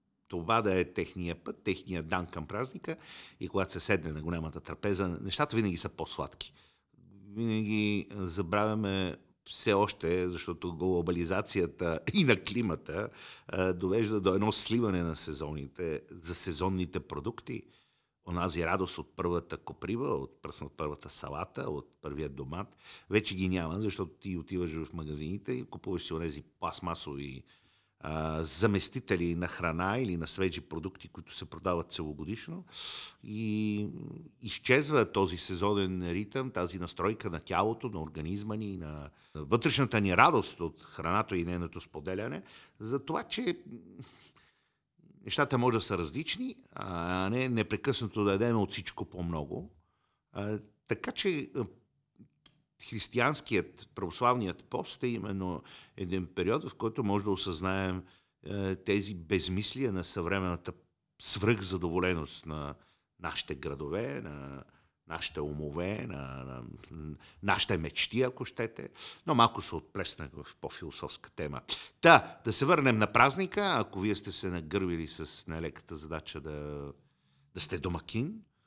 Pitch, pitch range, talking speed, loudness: 95 Hz, 85-105 Hz, 130 wpm, -32 LUFS